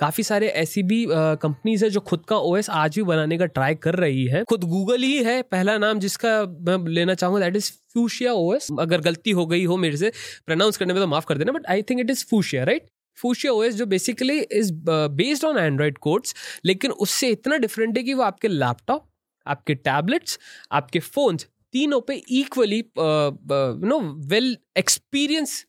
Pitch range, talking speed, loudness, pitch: 160-235 Hz, 190 wpm, -22 LUFS, 195 Hz